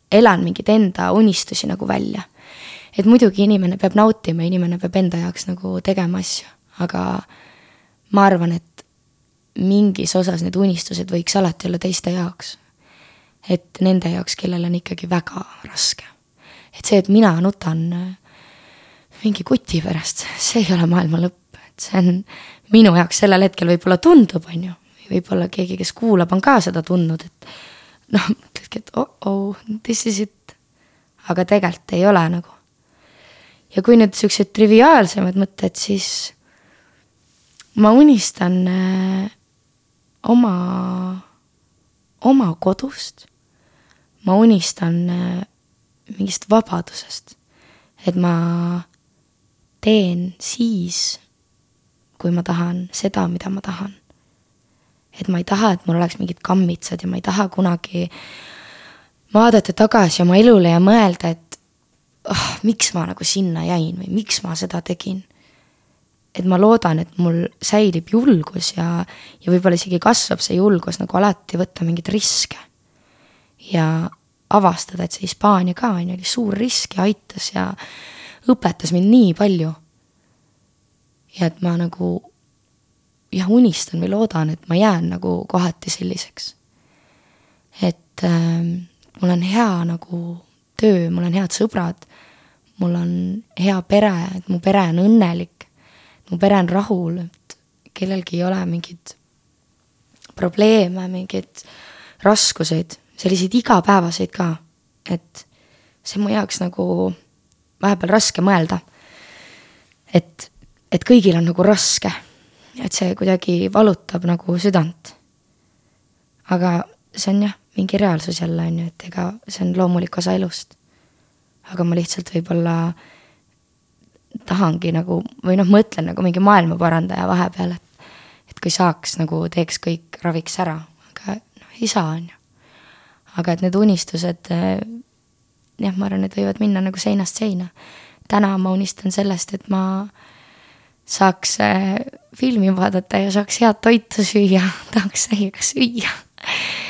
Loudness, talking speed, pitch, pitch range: -17 LUFS, 130 wpm, 185 Hz, 170-205 Hz